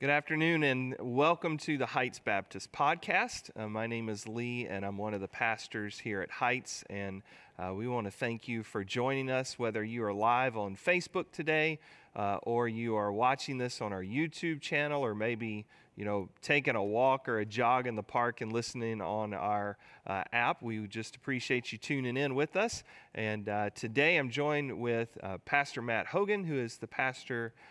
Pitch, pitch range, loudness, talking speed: 120 Hz, 105-140 Hz, -33 LUFS, 195 wpm